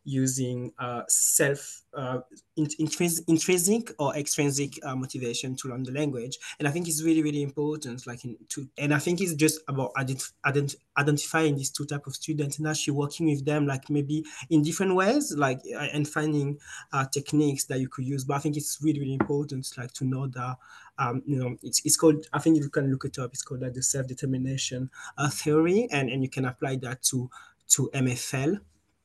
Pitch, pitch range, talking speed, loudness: 140 Hz, 130-150 Hz, 200 wpm, -27 LUFS